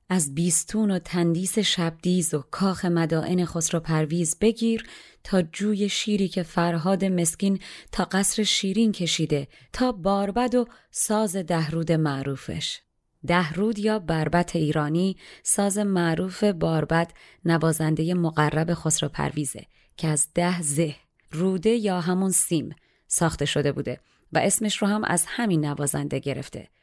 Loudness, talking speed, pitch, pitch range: -24 LUFS, 125 wpm, 175 Hz, 160-195 Hz